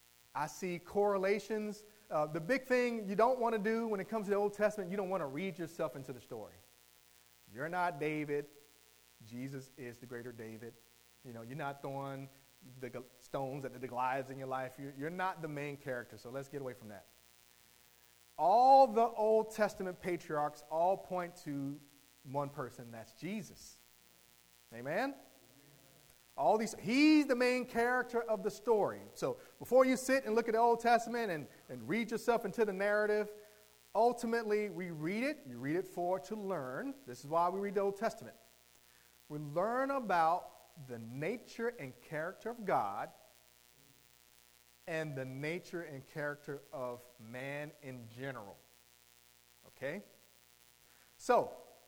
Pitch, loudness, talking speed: 150 Hz, -36 LUFS, 160 wpm